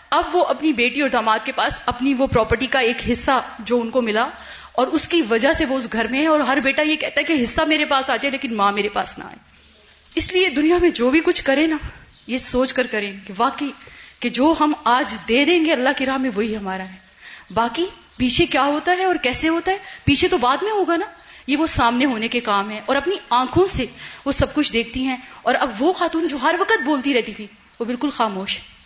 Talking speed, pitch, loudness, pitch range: 250 wpm, 270 Hz, -19 LUFS, 235-315 Hz